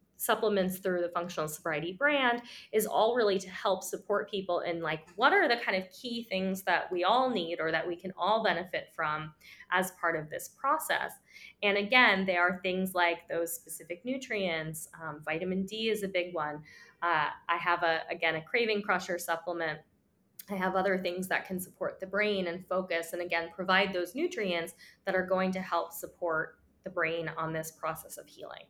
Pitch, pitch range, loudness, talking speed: 180 Hz, 170-200 Hz, -31 LUFS, 190 wpm